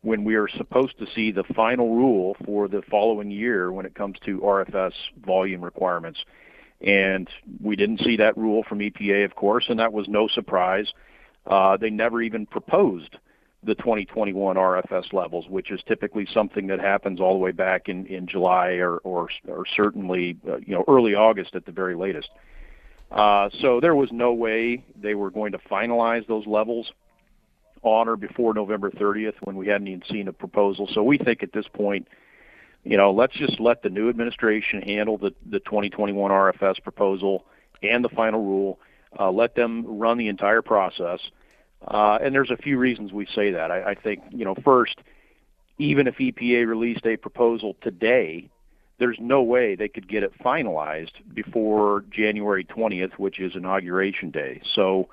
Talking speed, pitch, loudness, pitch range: 180 wpm, 105 Hz, -23 LUFS, 95-115 Hz